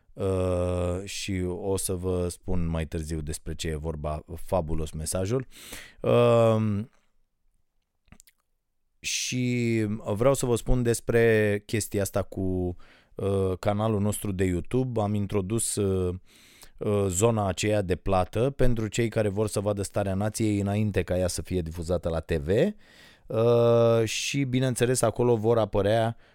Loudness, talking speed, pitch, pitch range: -26 LUFS, 130 wpm, 100 Hz, 90-115 Hz